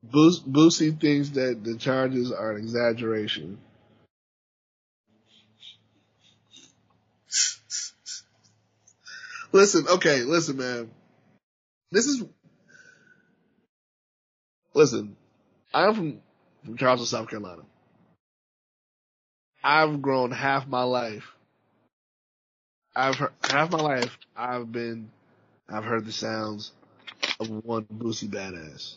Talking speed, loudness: 85 wpm, -25 LUFS